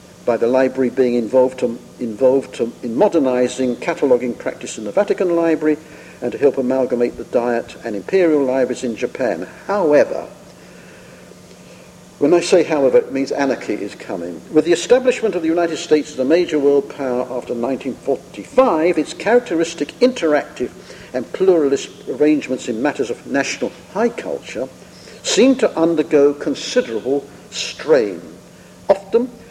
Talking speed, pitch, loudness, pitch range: 140 wpm, 150 Hz, -18 LUFS, 130-175 Hz